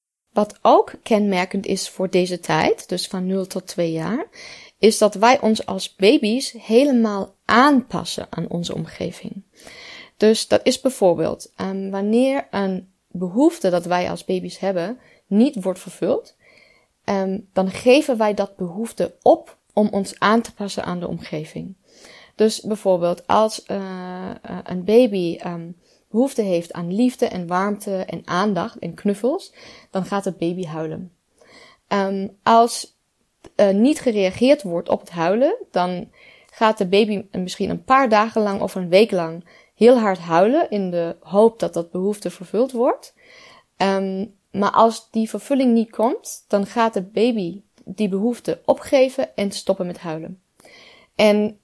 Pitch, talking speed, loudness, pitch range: 200 Hz, 150 wpm, -20 LUFS, 185-225 Hz